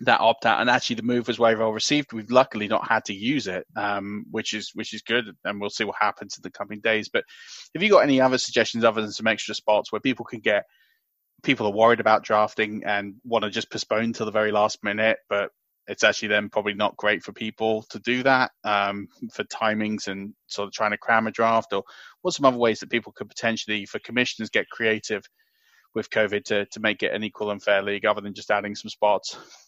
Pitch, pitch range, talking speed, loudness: 110 Hz, 105-115 Hz, 235 wpm, -24 LUFS